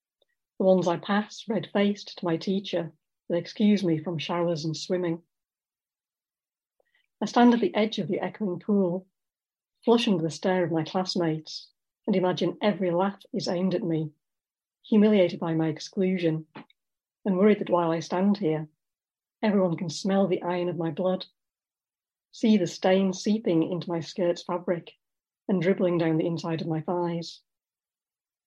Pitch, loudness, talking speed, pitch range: 180 Hz, -26 LUFS, 155 wpm, 170-200 Hz